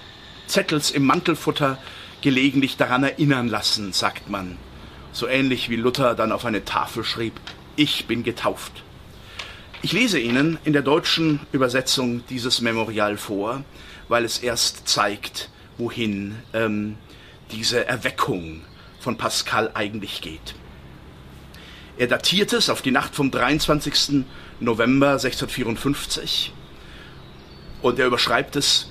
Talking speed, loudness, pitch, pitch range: 120 wpm, -21 LUFS, 115 Hz, 100-135 Hz